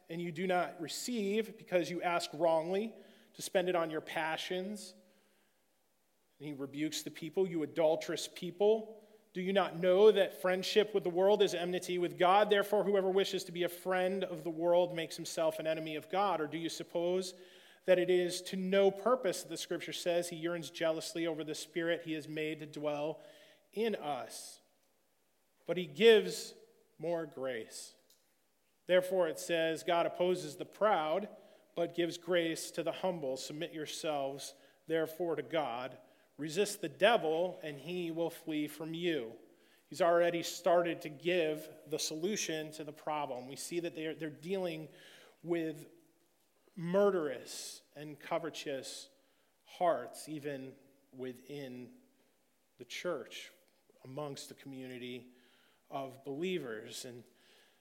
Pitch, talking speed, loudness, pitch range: 170 Hz, 145 wpm, -35 LUFS, 155-185 Hz